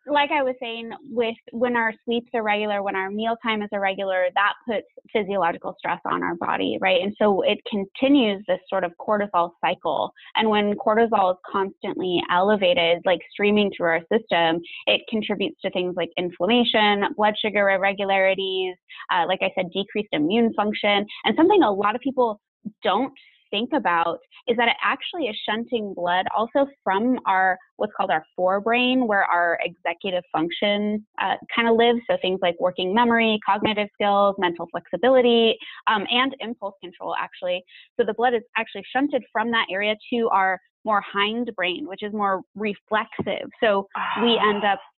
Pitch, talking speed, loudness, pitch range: 210 Hz, 170 wpm, -22 LUFS, 190-235 Hz